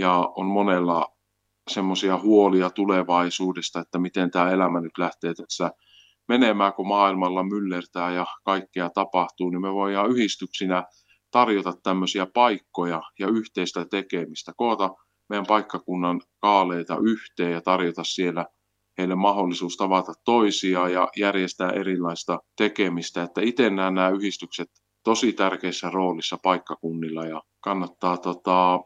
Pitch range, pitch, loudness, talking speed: 90-100 Hz, 95 Hz, -24 LUFS, 120 wpm